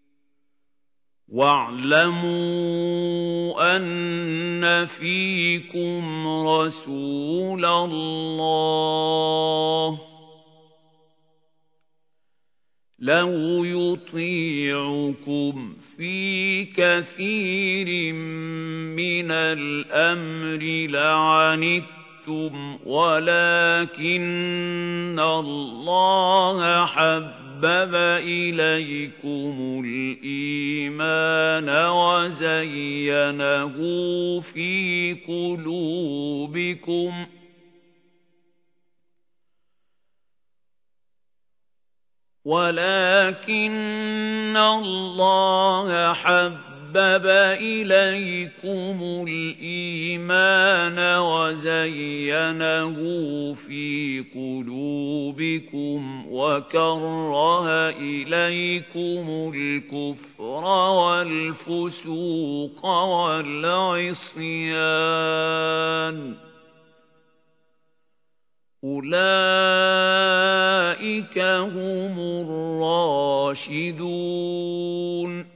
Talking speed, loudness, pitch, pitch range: 30 wpm, -22 LUFS, 165 Hz, 155-175 Hz